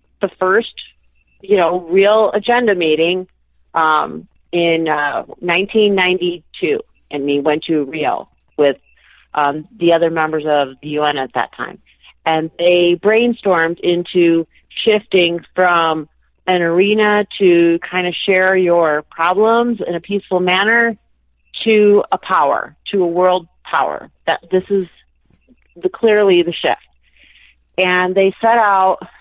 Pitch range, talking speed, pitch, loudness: 160-200 Hz, 135 wpm, 180 Hz, -15 LUFS